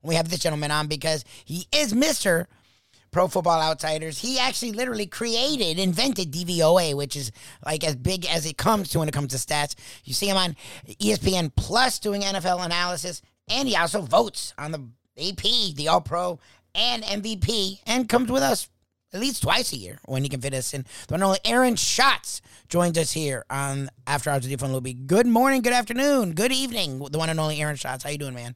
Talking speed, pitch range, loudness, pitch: 205 wpm, 140-205 Hz, -24 LUFS, 165 Hz